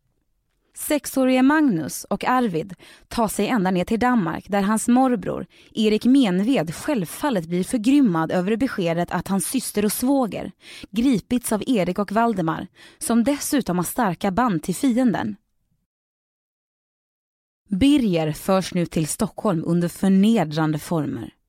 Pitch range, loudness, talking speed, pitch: 180-255 Hz, -21 LUFS, 125 wpm, 215 Hz